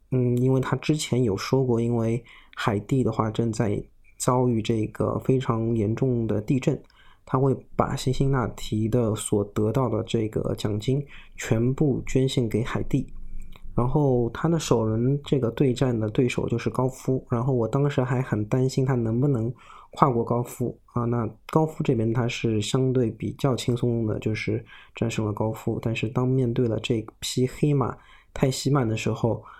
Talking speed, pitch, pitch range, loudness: 250 characters per minute, 120 Hz, 110-130 Hz, -25 LUFS